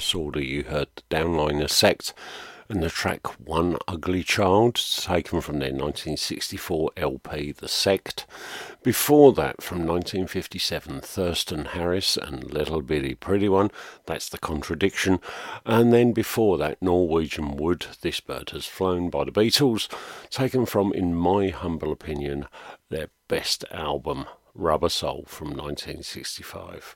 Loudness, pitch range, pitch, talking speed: -25 LUFS, 75-100 Hz, 90 Hz, 130 wpm